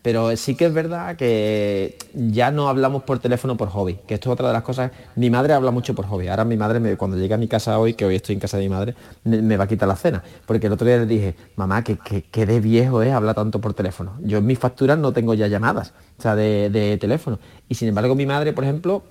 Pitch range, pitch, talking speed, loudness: 105-125 Hz, 115 Hz, 275 wpm, -20 LUFS